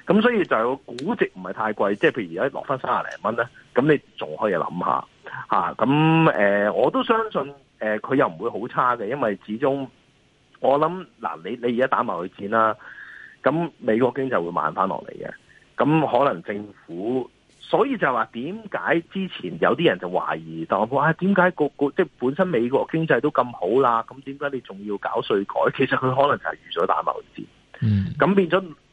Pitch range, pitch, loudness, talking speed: 105-160 Hz, 135 Hz, -22 LUFS, 280 characters per minute